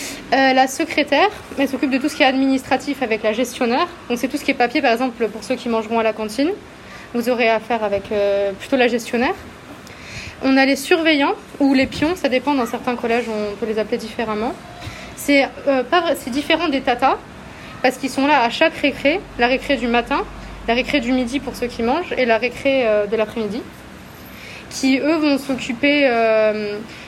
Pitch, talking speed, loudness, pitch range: 255 Hz, 205 wpm, -18 LUFS, 235-280 Hz